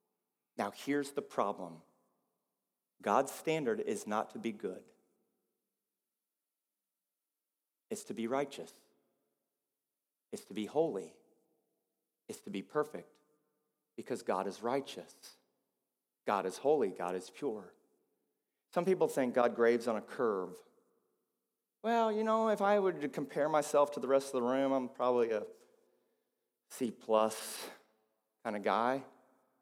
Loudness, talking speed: -35 LUFS, 130 wpm